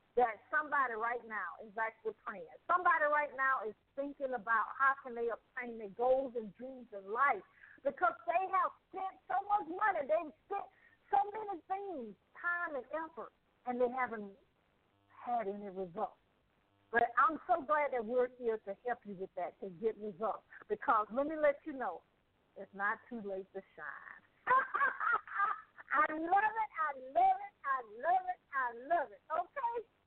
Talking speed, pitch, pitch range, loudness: 170 wpm, 275 Hz, 225-350 Hz, -36 LUFS